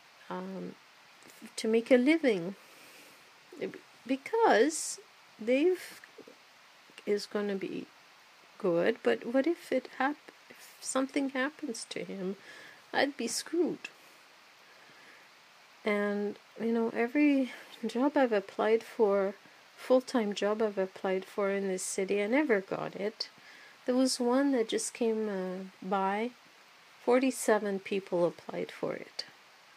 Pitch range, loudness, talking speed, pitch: 200-265 Hz, -31 LUFS, 120 wpm, 230 Hz